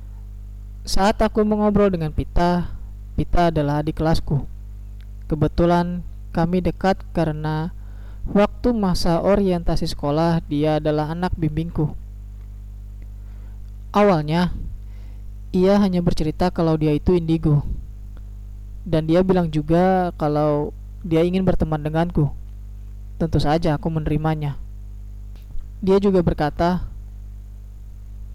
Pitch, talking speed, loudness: 155 Hz, 95 wpm, -21 LUFS